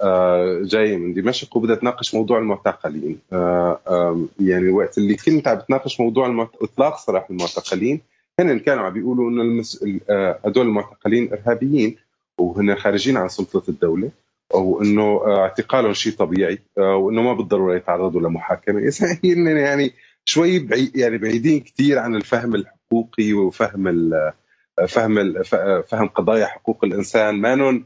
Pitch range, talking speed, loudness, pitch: 95-125 Hz, 145 wpm, -19 LUFS, 110 Hz